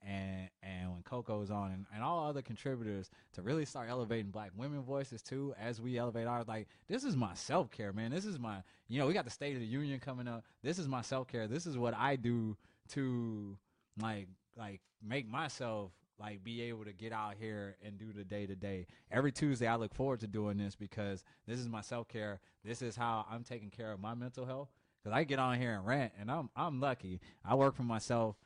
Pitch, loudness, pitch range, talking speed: 115 Hz, -40 LUFS, 105-130 Hz, 230 wpm